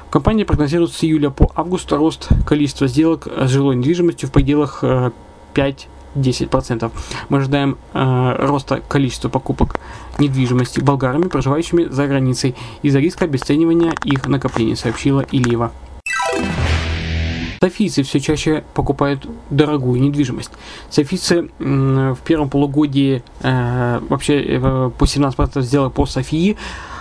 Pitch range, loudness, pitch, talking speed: 130-150 Hz, -17 LUFS, 140 Hz, 105 wpm